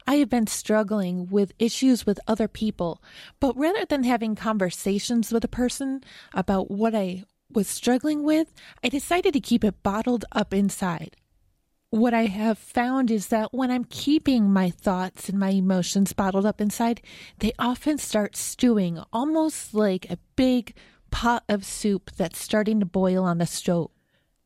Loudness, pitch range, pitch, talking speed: -24 LUFS, 195-245 Hz, 215 Hz, 160 wpm